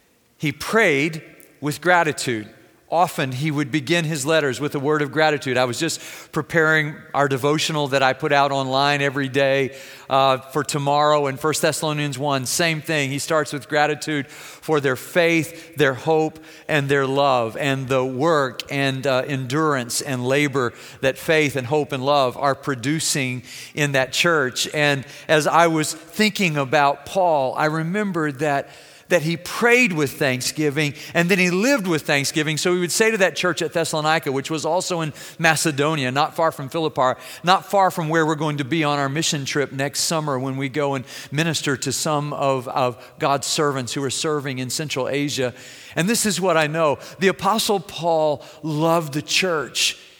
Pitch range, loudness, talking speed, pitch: 140-160 Hz, -20 LUFS, 180 wpm, 150 Hz